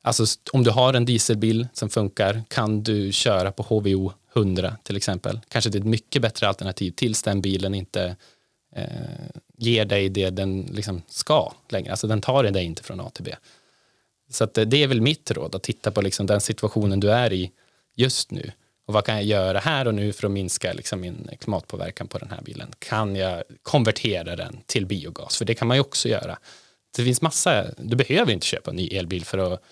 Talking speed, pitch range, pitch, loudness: 210 wpm, 95-120 Hz, 110 Hz, -23 LUFS